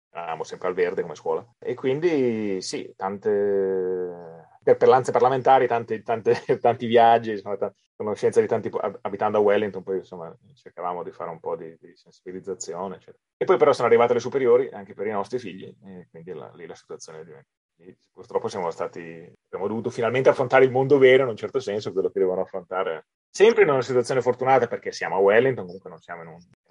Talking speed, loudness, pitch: 195 wpm, -23 LUFS, 135 Hz